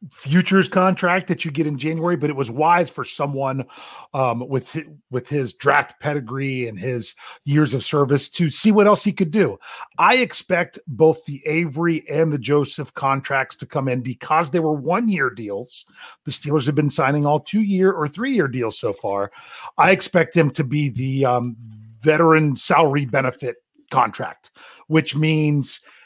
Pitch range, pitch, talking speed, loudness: 135-170 Hz, 150 Hz, 175 wpm, -20 LUFS